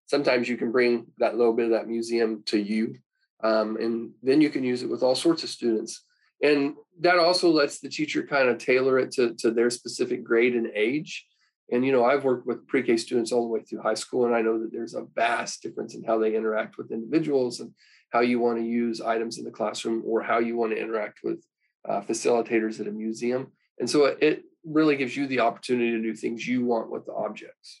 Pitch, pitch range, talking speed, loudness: 120 Hz, 115-130 Hz, 230 wpm, -25 LUFS